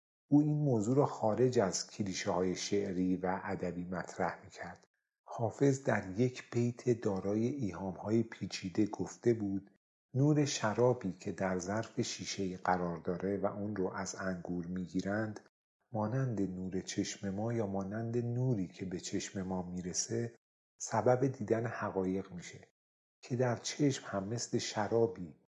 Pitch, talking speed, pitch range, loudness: 100 Hz, 140 wpm, 95-120 Hz, -35 LUFS